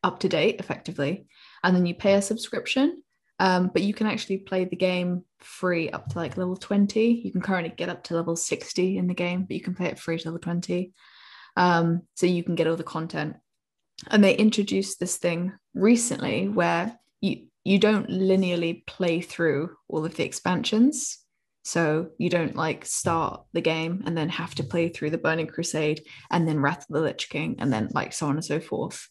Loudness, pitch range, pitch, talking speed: -26 LUFS, 165-195 Hz, 180 Hz, 205 wpm